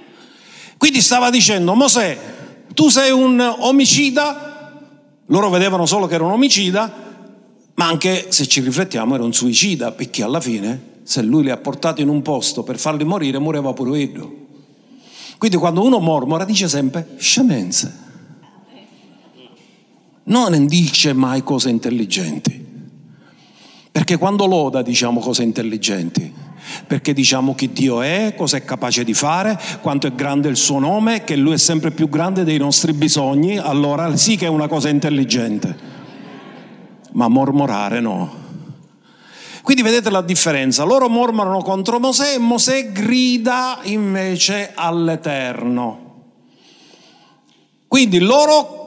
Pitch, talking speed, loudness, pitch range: 170 Hz, 135 wpm, -15 LUFS, 140-225 Hz